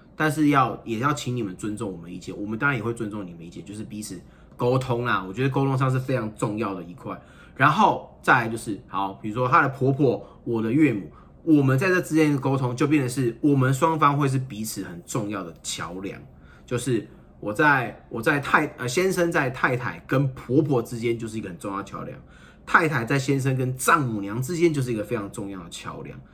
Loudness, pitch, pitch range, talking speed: -24 LUFS, 125 Hz, 110-145 Hz, 325 characters per minute